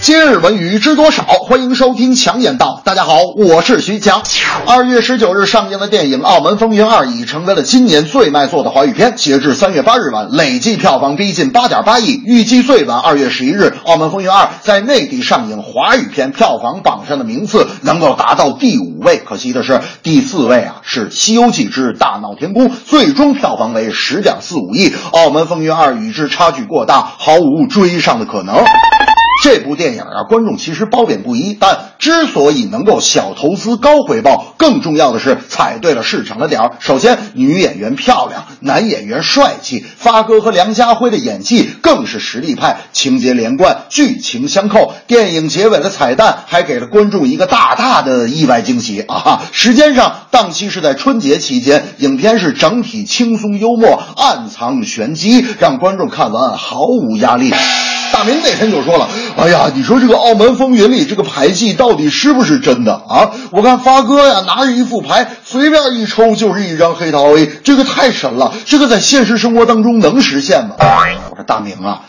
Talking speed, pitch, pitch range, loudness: 290 characters per minute, 235 Hz, 205-255 Hz, -10 LUFS